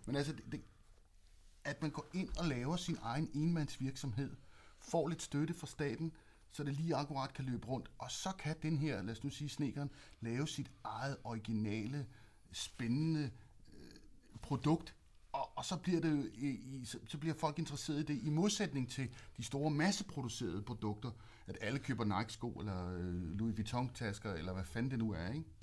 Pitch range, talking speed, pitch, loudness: 110-150 Hz, 185 wpm, 130 Hz, -41 LUFS